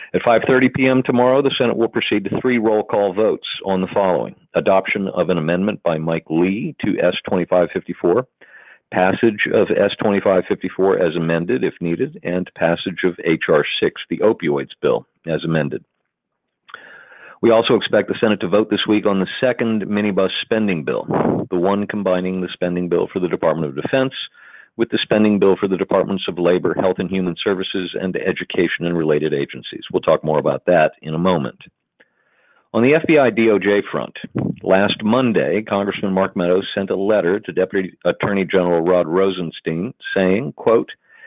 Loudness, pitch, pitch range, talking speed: -18 LUFS, 95 Hz, 90-105 Hz, 165 wpm